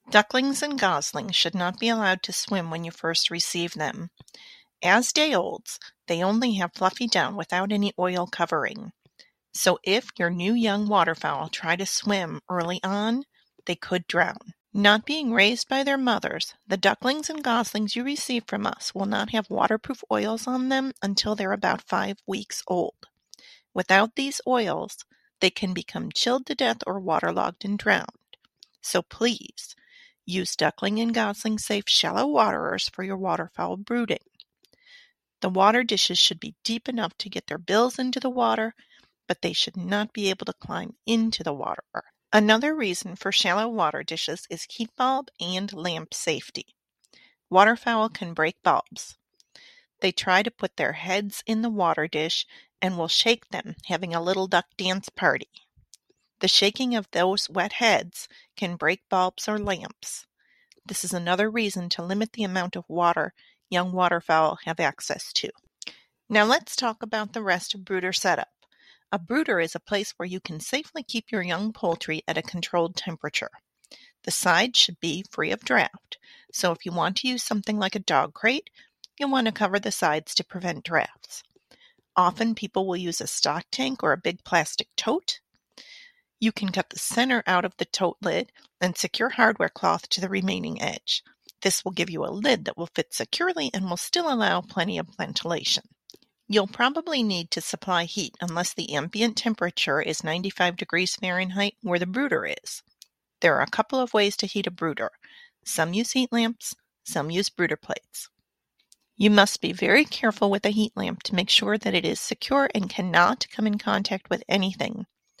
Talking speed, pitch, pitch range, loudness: 175 wpm, 200 Hz, 180-230 Hz, -25 LUFS